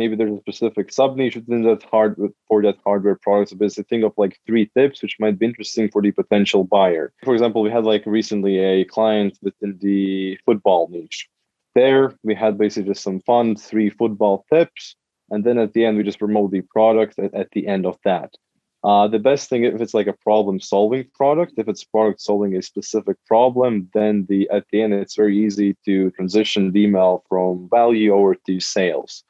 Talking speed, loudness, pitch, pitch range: 205 wpm, -19 LUFS, 105 Hz, 100-110 Hz